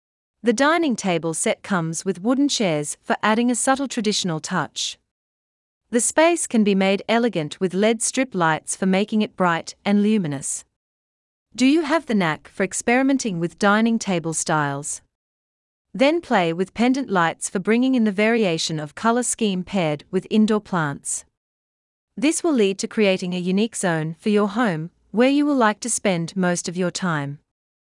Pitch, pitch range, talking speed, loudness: 195 Hz, 160-230 Hz, 170 wpm, -21 LUFS